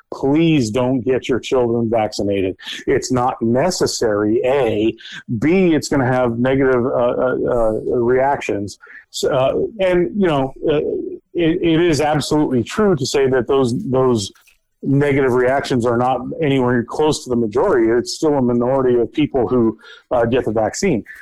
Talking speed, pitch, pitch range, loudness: 155 wpm, 130 Hz, 120-150 Hz, -17 LUFS